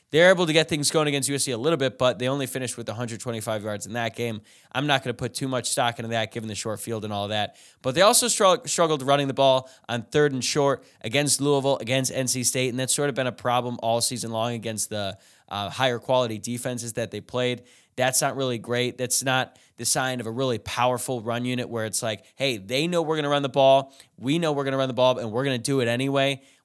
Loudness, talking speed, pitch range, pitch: -24 LUFS, 260 wpm, 115-135 Hz, 125 Hz